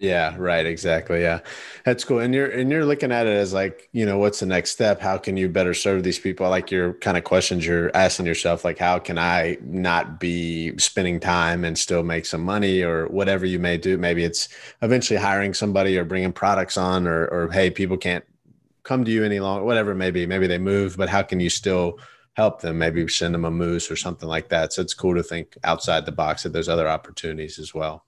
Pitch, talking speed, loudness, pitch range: 90 Hz, 235 wpm, -22 LUFS, 85-95 Hz